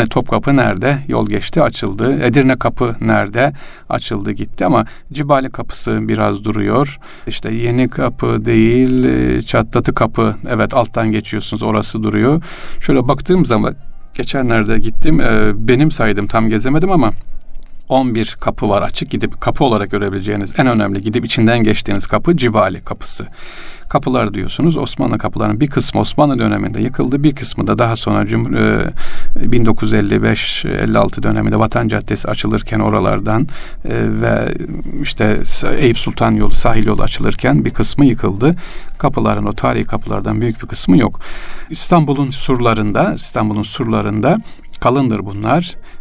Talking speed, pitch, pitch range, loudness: 130 wpm, 115 Hz, 105-130 Hz, -15 LUFS